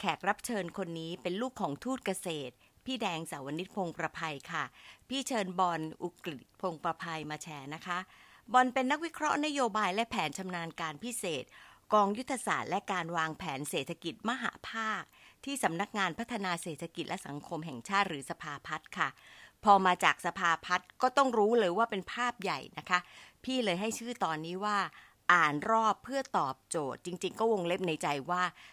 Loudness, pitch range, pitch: -33 LUFS, 165-225 Hz, 185 Hz